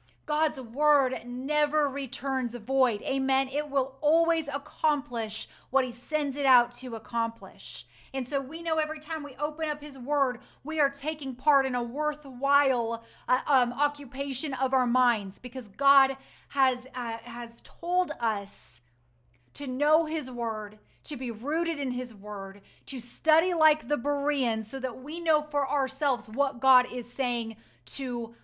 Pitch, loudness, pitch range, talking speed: 270 Hz, -28 LUFS, 245-295 Hz, 160 wpm